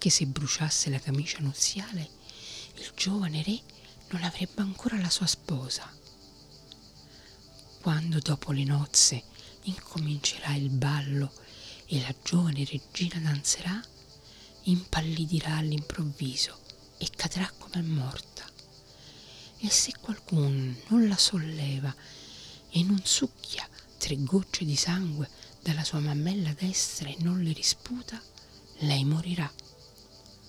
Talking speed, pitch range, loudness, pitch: 110 wpm, 135-180 Hz, -29 LUFS, 150 Hz